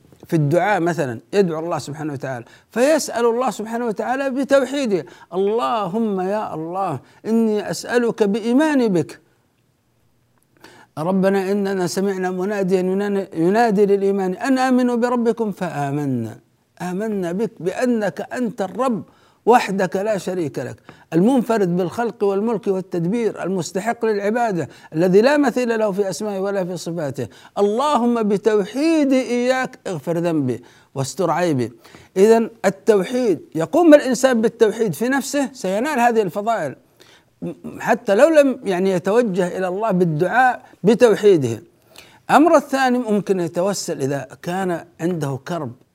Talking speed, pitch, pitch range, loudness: 115 wpm, 200 Hz, 175-235 Hz, -19 LUFS